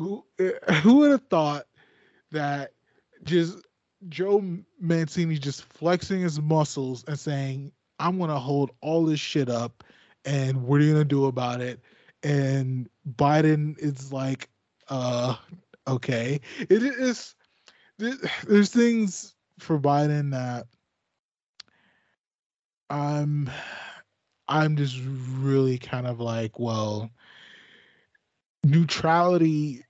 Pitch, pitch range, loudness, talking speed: 145 Hz, 135-170 Hz, -25 LUFS, 105 wpm